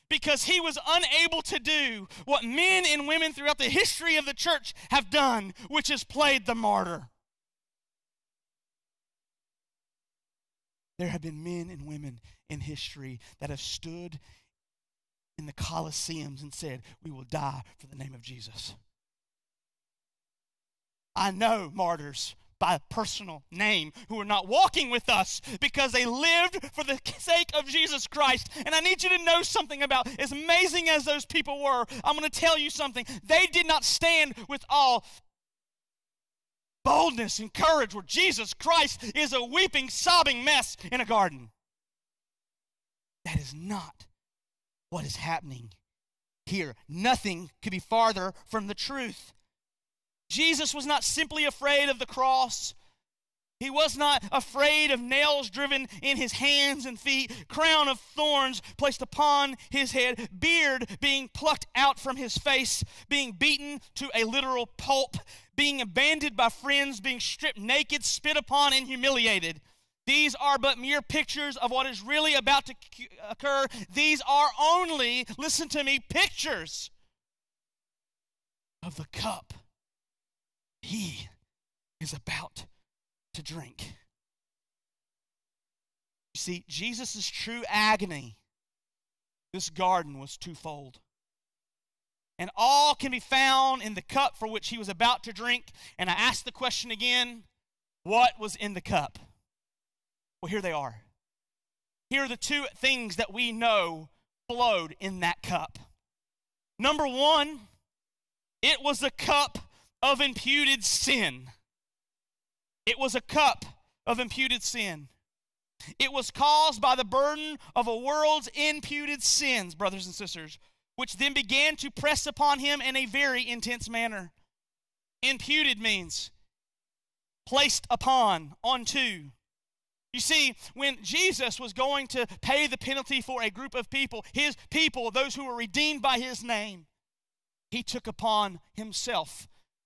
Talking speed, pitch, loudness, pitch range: 140 wpm, 255 Hz, -26 LUFS, 200-290 Hz